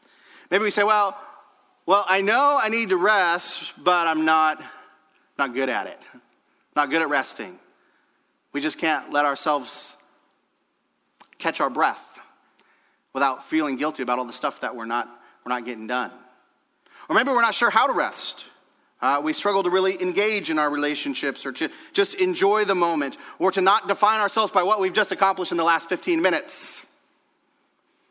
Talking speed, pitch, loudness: 175 wpm, 195 Hz, -22 LUFS